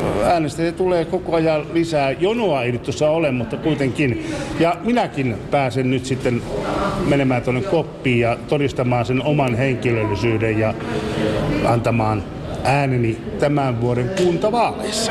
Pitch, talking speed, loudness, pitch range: 135 Hz, 125 wpm, -19 LUFS, 120-155 Hz